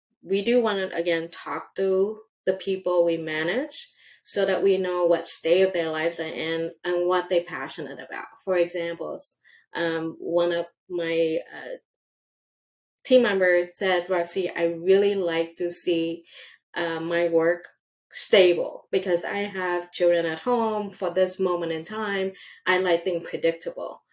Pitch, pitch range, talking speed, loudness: 175 Hz, 170-195 Hz, 155 wpm, -25 LUFS